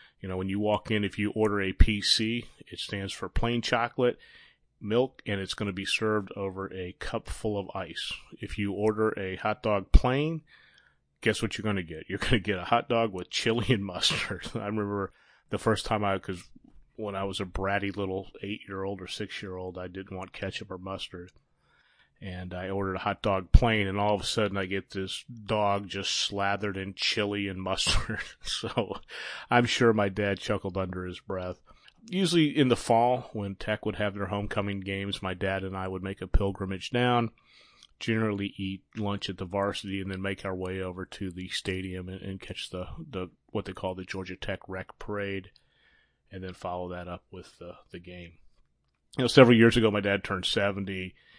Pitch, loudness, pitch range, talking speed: 100 Hz, -29 LUFS, 95-105 Hz, 205 wpm